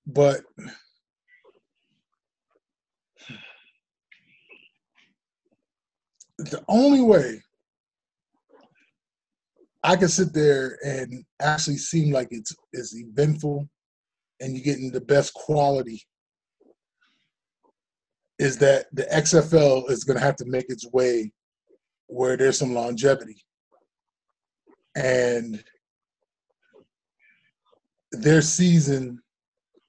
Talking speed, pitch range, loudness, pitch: 80 wpm, 130-160 Hz, -22 LUFS, 140 Hz